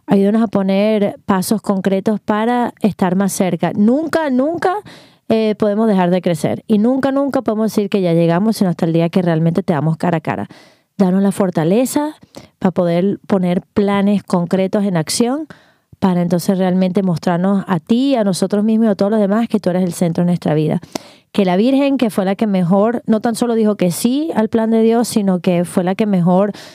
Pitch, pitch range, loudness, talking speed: 200 Hz, 185-225 Hz, -16 LUFS, 205 wpm